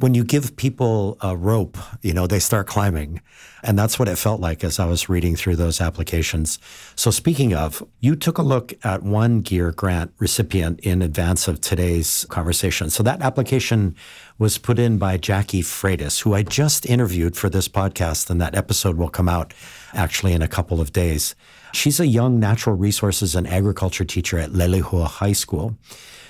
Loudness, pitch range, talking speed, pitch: -20 LUFS, 85-110 Hz, 185 wpm, 95 Hz